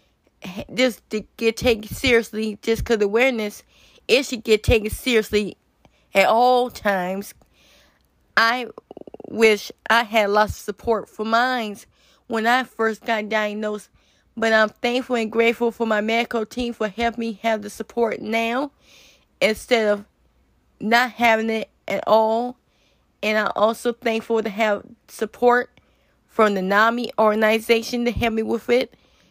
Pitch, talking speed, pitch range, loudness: 225 Hz, 145 wpm, 215-240 Hz, -21 LUFS